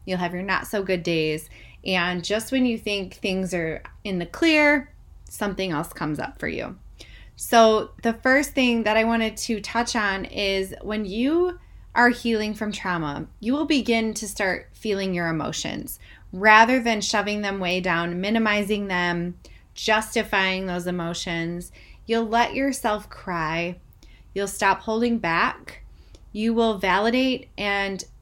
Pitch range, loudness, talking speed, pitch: 180-230 Hz, -23 LUFS, 150 wpm, 210 Hz